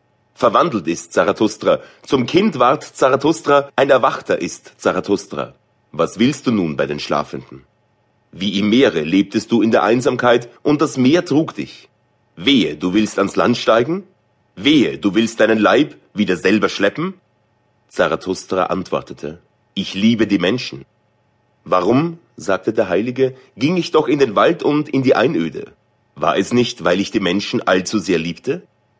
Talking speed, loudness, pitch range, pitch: 155 wpm, -17 LUFS, 95-135 Hz, 115 Hz